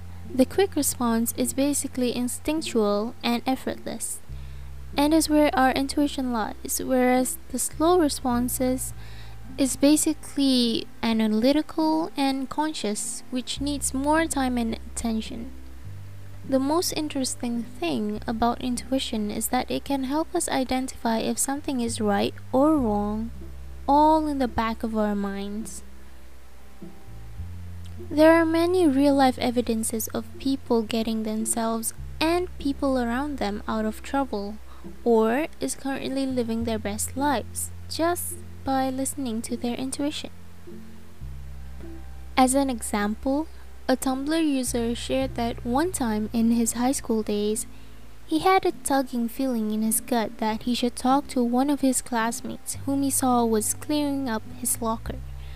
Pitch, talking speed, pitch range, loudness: 240 Hz, 135 wpm, 210-275 Hz, -25 LUFS